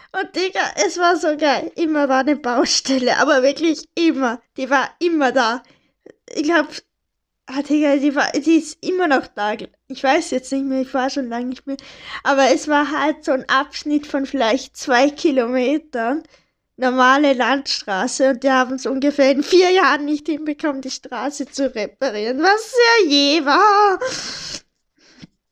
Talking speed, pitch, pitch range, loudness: 165 wpm, 280 Hz, 265-320 Hz, -18 LUFS